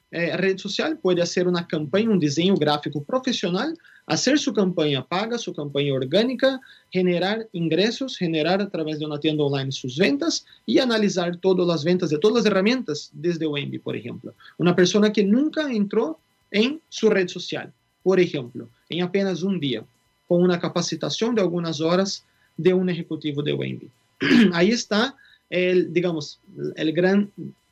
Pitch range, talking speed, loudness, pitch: 155-210 Hz, 160 wpm, -22 LUFS, 180 Hz